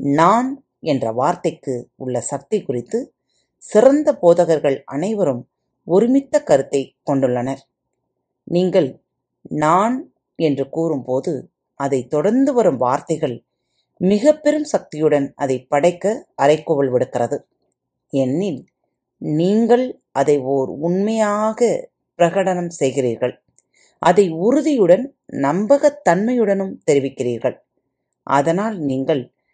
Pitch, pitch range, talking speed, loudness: 165 Hz, 135-210 Hz, 80 wpm, -18 LUFS